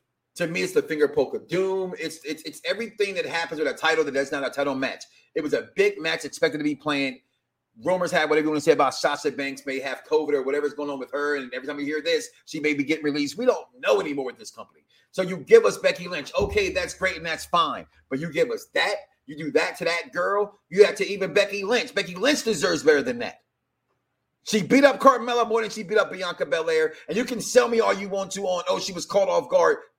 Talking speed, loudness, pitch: 260 wpm, -24 LUFS, 195 Hz